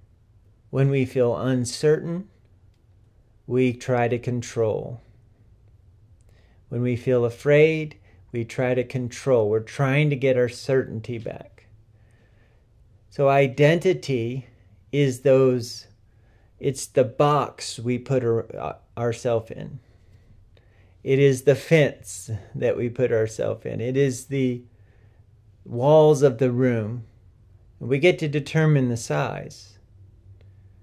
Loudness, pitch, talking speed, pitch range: -22 LUFS, 120 Hz, 110 wpm, 105-135 Hz